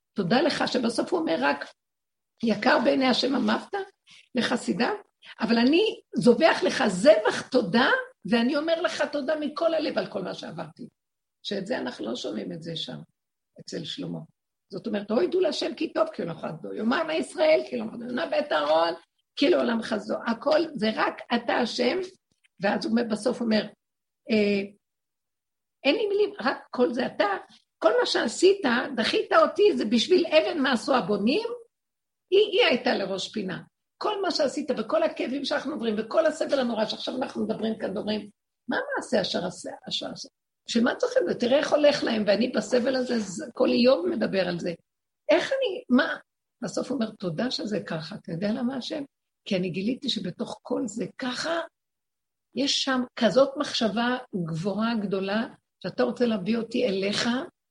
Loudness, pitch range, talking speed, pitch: -26 LUFS, 220-310 Hz, 160 wpm, 255 Hz